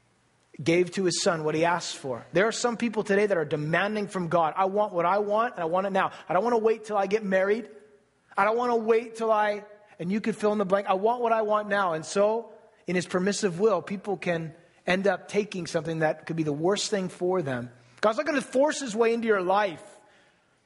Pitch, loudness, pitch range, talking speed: 200 Hz, -26 LUFS, 175-215 Hz, 255 wpm